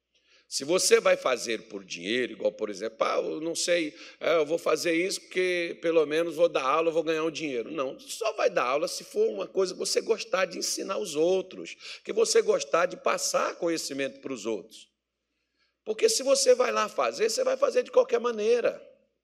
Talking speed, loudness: 195 wpm, -27 LUFS